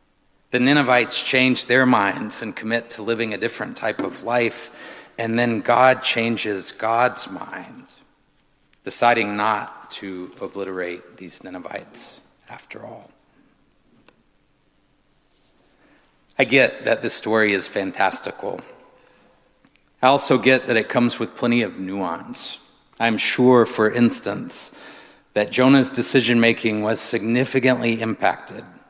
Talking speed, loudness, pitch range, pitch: 115 wpm, -20 LUFS, 105-125 Hz, 115 Hz